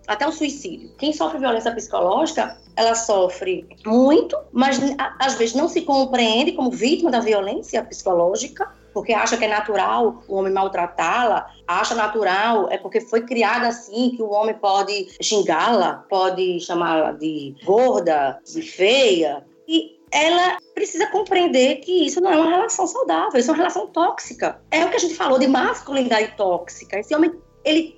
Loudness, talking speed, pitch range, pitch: -20 LUFS, 160 wpm, 210-325 Hz, 250 Hz